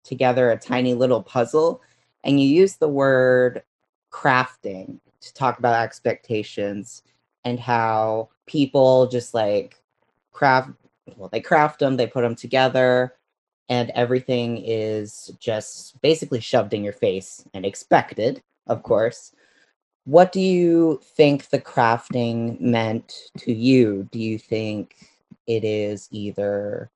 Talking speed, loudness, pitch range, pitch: 125 wpm, -21 LUFS, 110-135 Hz, 125 Hz